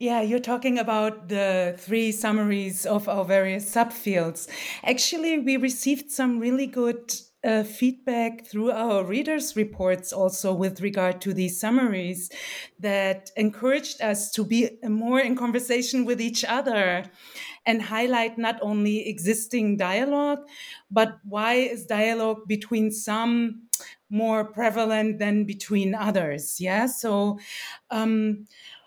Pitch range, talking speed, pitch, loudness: 205-240 Hz, 125 wpm, 220 Hz, -25 LUFS